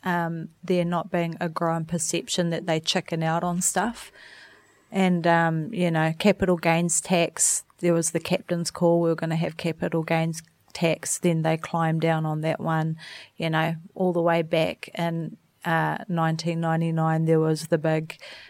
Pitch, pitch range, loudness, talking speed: 165 Hz, 160-175 Hz, -25 LUFS, 175 wpm